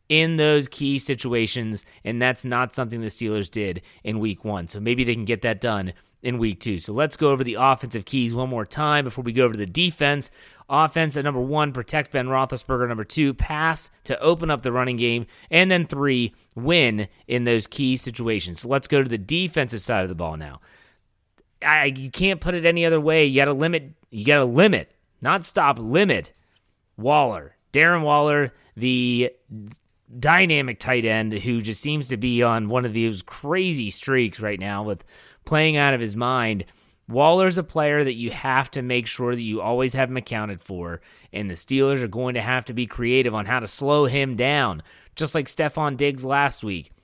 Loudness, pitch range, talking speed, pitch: -22 LUFS, 110-145 Hz, 205 wpm, 125 Hz